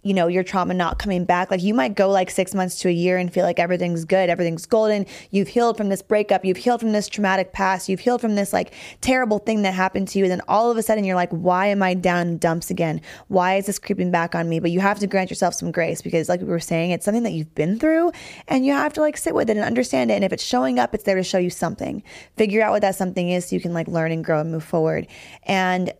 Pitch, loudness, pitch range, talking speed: 190 Hz, -21 LUFS, 175-205 Hz, 290 wpm